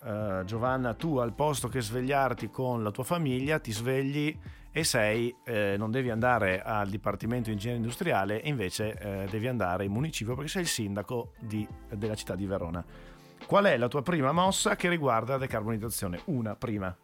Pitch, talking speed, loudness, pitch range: 115 Hz, 180 wpm, -30 LUFS, 105-135 Hz